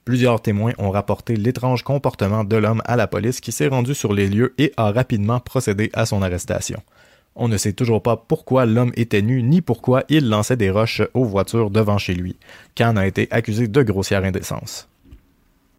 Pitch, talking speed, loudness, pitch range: 115 Hz, 195 wpm, -19 LUFS, 100-125 Hz